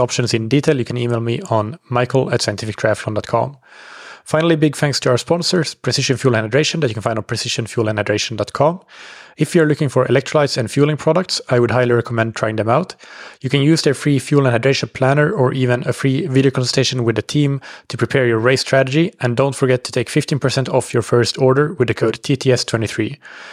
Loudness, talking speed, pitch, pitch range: -17 LUFS, 205 wpm, 130 Hz, 120-145 Hz